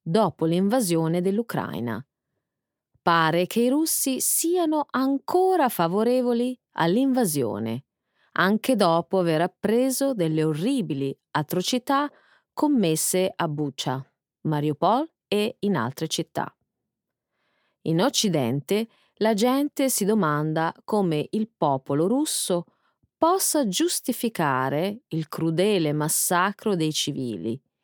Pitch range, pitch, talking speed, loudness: 160-255 Hz, 195 Hz, 95 wpm, -24 LUFS